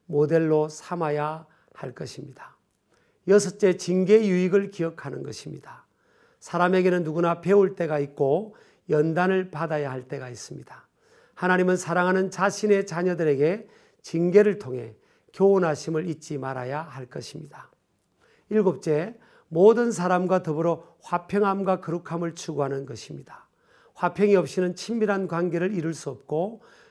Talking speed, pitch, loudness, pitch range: 300 characters per minute, 175 Hz, -24 LUFS, 155-195 Hz